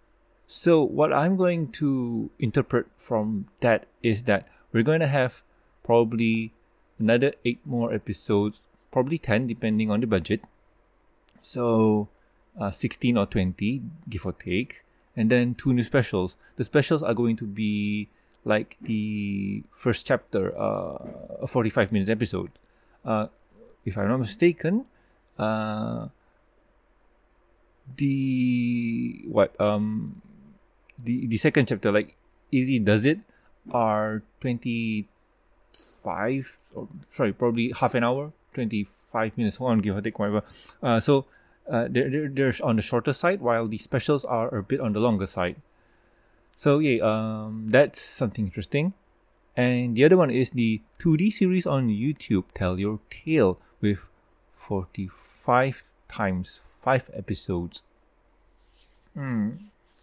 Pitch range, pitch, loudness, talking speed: 105-135 Hz, 115 Hz, -25 LUFS, 130 wpm